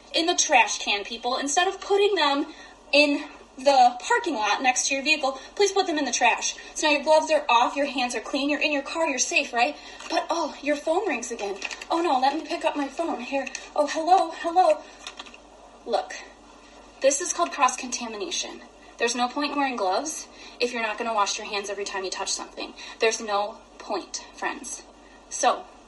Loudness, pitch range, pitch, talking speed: -24 LUFS, 240-325 Hz, 285 Hz, 205 wpm